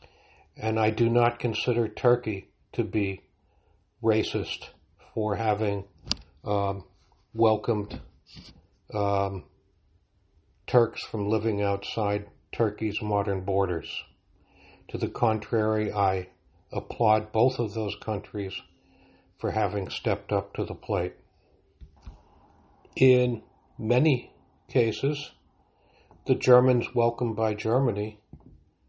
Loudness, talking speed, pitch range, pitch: -27 LUFS, 95 wpm, 95-115 Hz, 105 Hz